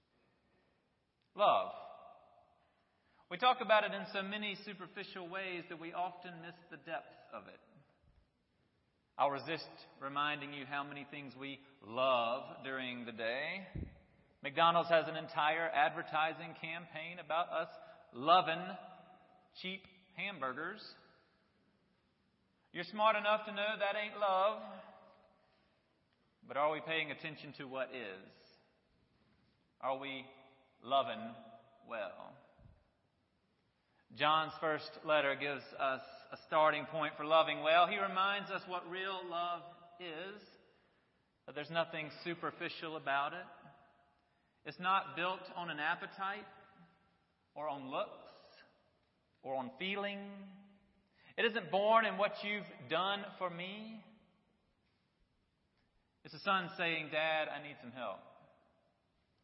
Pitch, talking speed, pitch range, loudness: 170 Hz, 115 wpm, 145-195 Hz, -37 LUFS